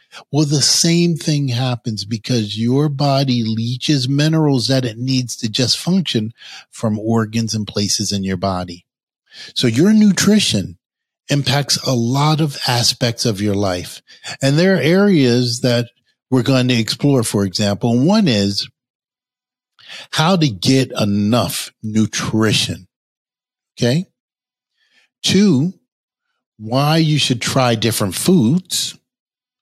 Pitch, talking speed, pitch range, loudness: 125 Hz, 120 wpm, 115-150 Hz, -16 LUFS